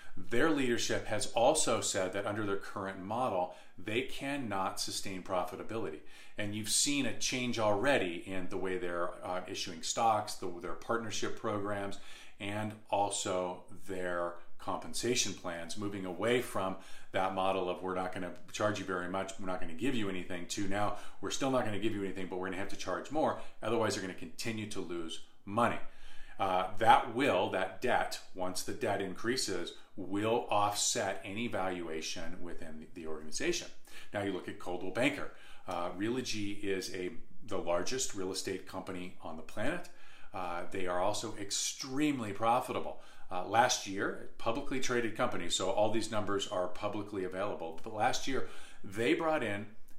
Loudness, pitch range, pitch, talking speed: -35 LUFS, 90-110 Hz, 100 Hz, 170 wpm